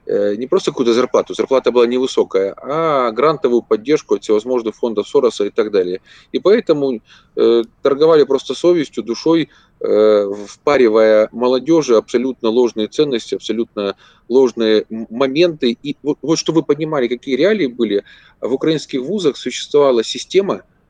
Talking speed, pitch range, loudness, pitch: 135 wpm, 110-165 Hz, -16 LUFS, 130 Hz